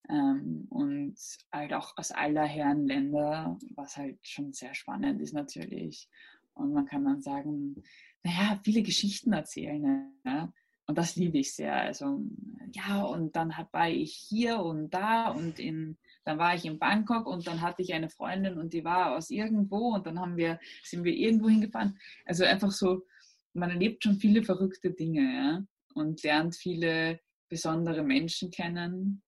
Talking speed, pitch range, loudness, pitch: 170 wpm, 165-230 Hz, -31 LUFS, 185 Hz